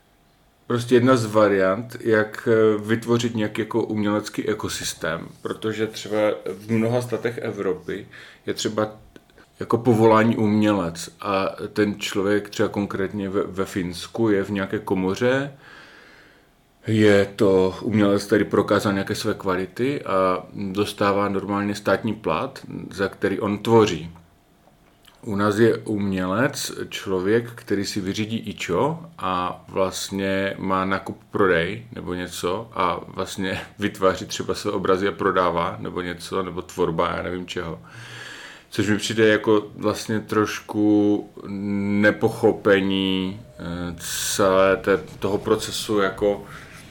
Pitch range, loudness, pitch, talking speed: 95-110 Hz, -22 LUFS, 100 Hz, 120 wpm